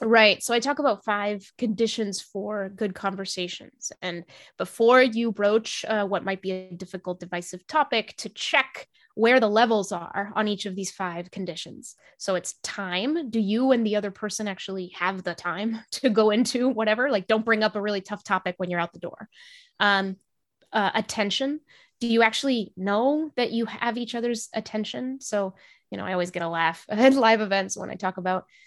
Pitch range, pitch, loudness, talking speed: 190-235 Hz, 210 Hz, -25 LUFS, 195 wpm